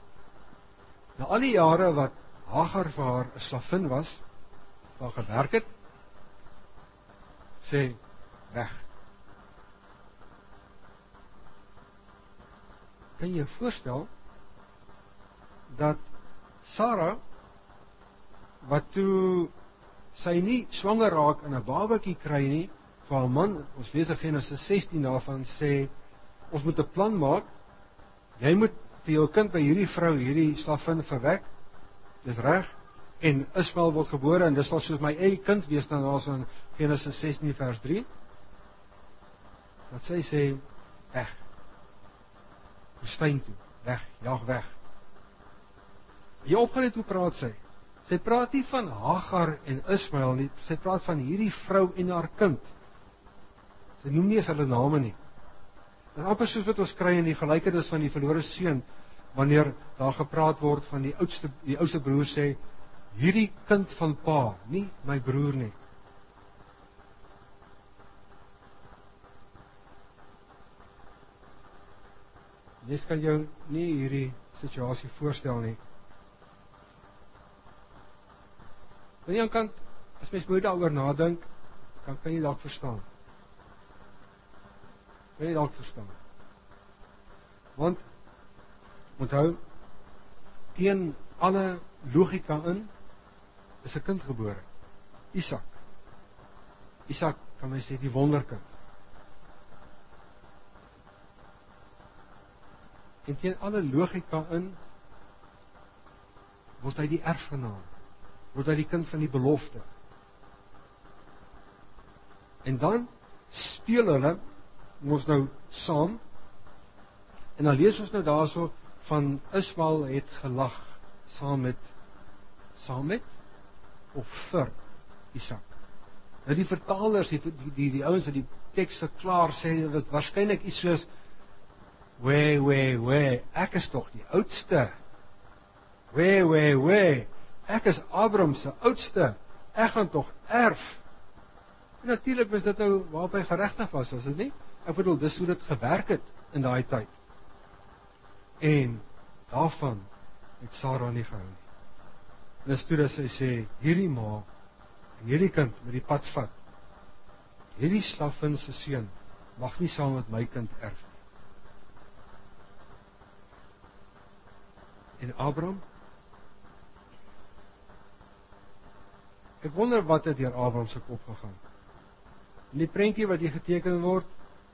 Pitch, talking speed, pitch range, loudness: 110 Hz, 115 wpm, 100-150 Hz, -28 LUFS